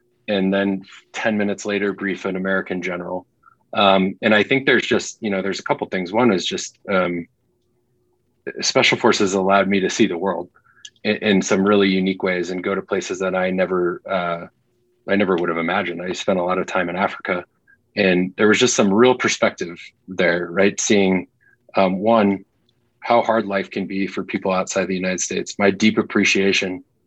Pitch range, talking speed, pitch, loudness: 95-110 Hz, 195 wpm, 100 Hz, -19 LUFS